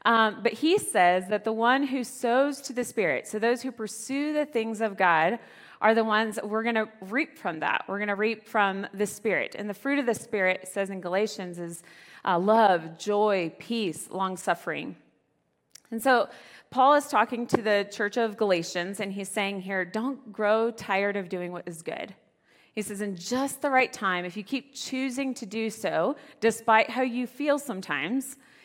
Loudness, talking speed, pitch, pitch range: -27 LUFS, 200 wpm, 220 Hz, 195-250 Hz